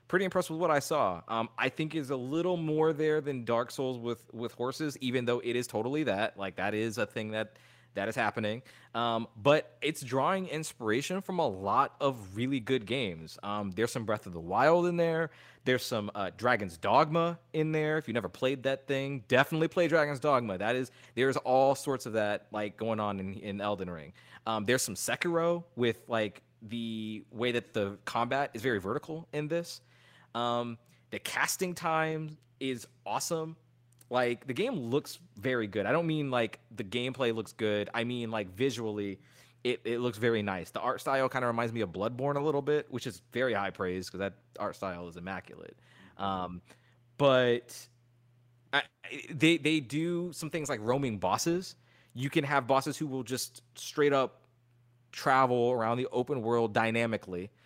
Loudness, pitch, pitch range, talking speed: -32 LUFS, 125 Hz, 115-145 Hz, 190 wpm